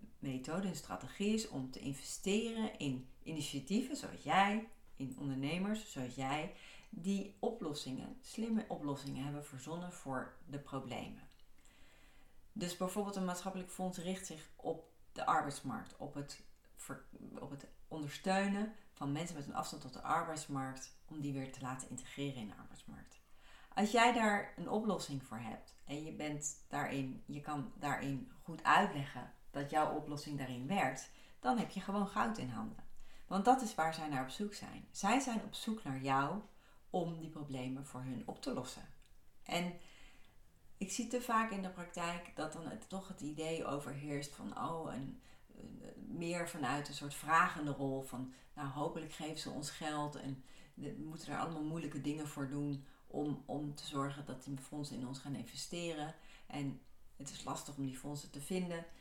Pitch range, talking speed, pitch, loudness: 140-185 Hz, 170 wpm, 150 Hz, -41 LUFS